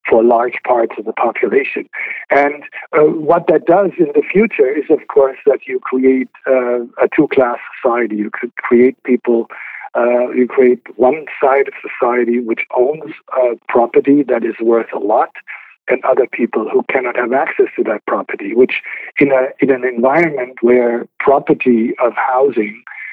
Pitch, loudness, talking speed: 130 Hz, -14 LUFS, 165 wpm